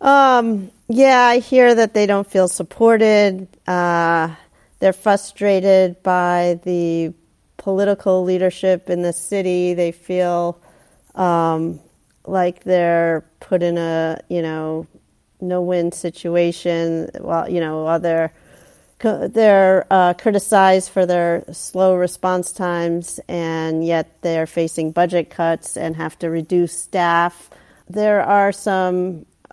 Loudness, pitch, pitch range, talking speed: -17 LUFS, 180 Hz, 170-190 Hz, 120 wpm